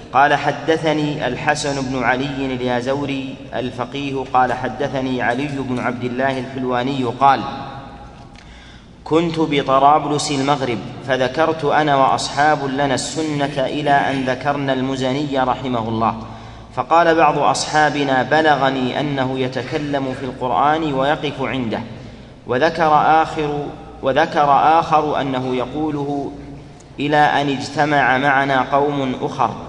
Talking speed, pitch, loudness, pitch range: 105 wpm, 135 Hz, -18 LUFS, 130-145 Hz